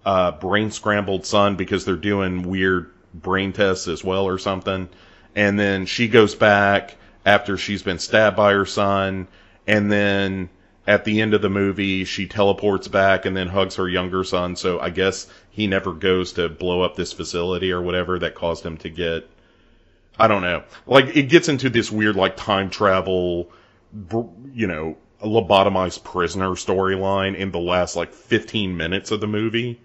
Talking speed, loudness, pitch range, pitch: 175 wpm, -20 LUFS, 90-105 Hz, 95 Hz